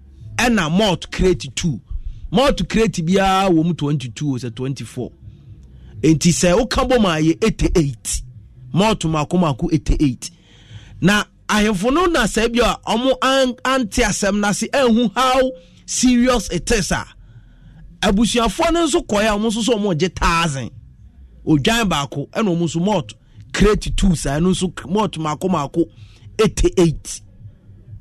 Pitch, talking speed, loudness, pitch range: 175 Hz, 165 wpm, -18 LUFS, 135-220 Hz